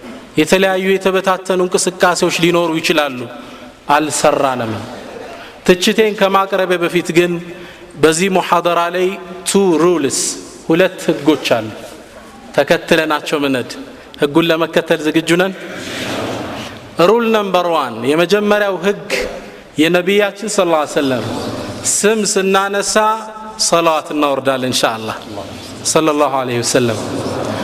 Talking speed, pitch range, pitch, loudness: 85 wpm, 150-190 Hz, 175 Hz, -14 LUFS